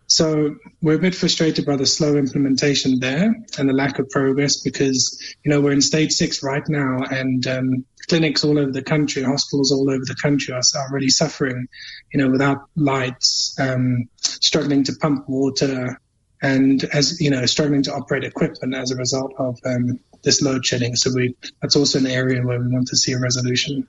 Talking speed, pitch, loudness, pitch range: 195 wpm, 135 Hz, -19 LUFS, 130-145 Hz